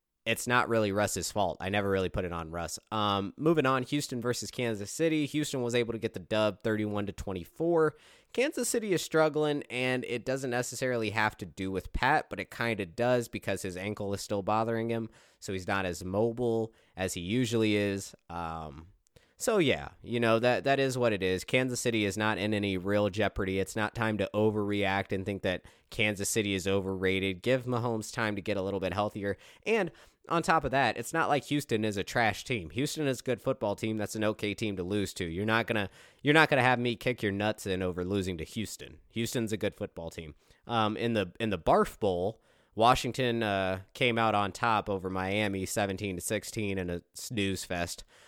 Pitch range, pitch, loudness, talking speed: 95-120 Hz, 105 Hz, -30 LUFS, 215 wpm